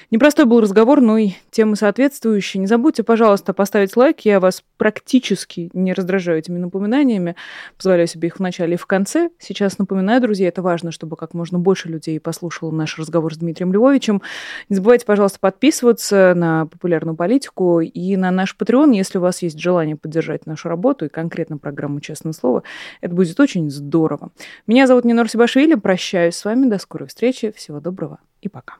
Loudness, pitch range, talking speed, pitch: -17 LUFS, 170-220 Hz, 175 wpm, 190 Hz